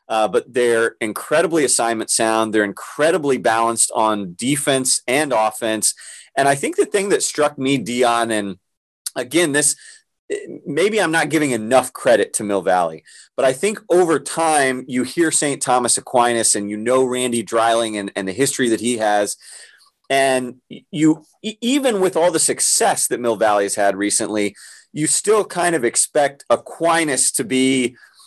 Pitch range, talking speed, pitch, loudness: 115-155 Hz, 165 wpm, 130 Hz, -18 LUFS